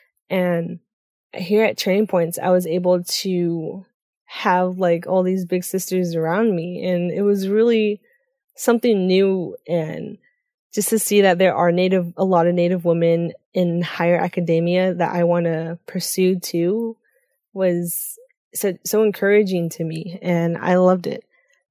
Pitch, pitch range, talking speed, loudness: 185 Hz, 175-210 Hz, 150 wpm, -19 LUFS